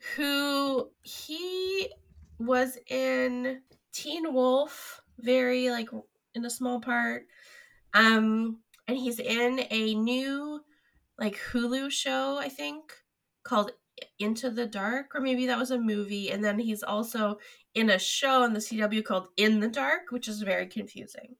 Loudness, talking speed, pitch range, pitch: -29 LUFS, 145 wpm, 220-275 Hz, 250 Hz